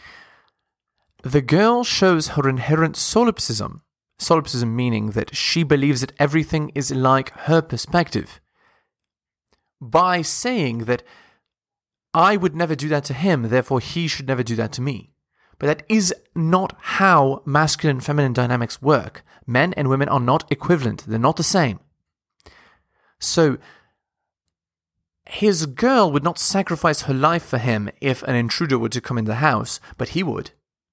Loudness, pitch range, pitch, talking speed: -19 LUFS, 125-170 Hz, 145 Hz, 150 wpm